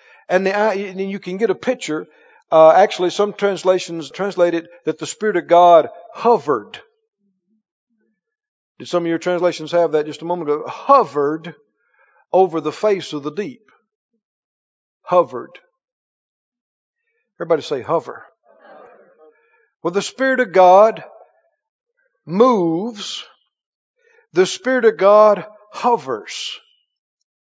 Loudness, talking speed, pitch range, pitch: -17 LUFS, 115 wpm, 170-245 Hz, 200 Hz